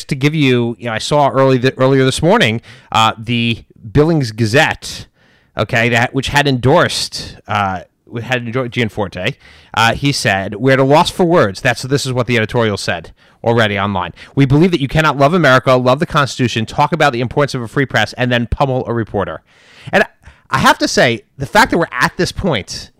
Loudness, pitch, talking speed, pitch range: -14 LUFS, 130 Hz, 205 wpm, 115-140 Hz